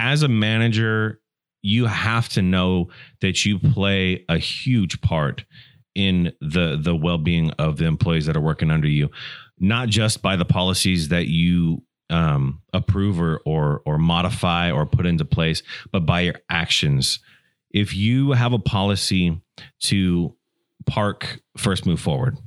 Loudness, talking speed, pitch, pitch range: -21 LUFS, 150 wpm, 95 Hz, 85-110 Hz